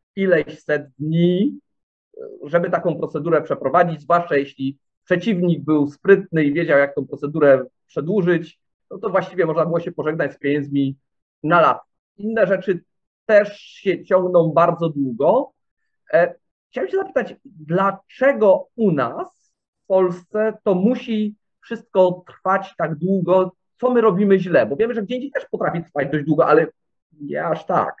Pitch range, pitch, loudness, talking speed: 155-205 Hz, 180 Hz, -19 LUFS, 145 wpm